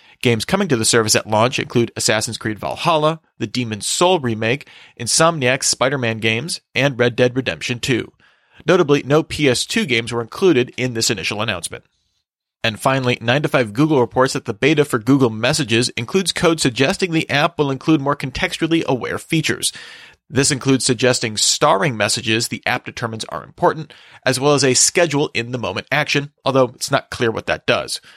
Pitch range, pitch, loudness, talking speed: 115-145 Hz, 125 Hz, -17 LUFS, 180 wpm